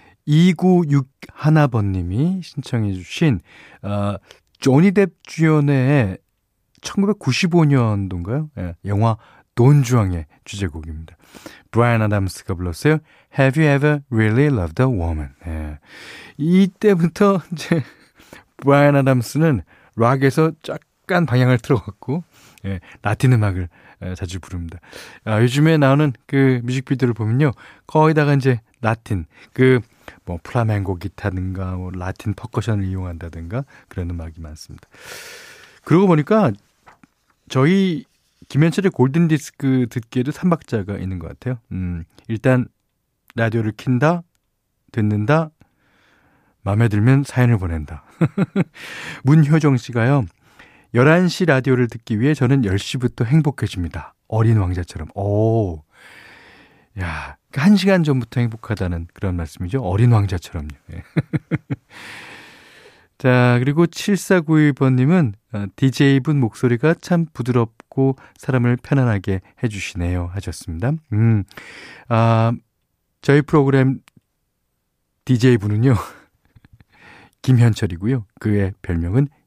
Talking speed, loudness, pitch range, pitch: 255 characters per minute, -18 LUFS, 100-145 Hz, 120 Hz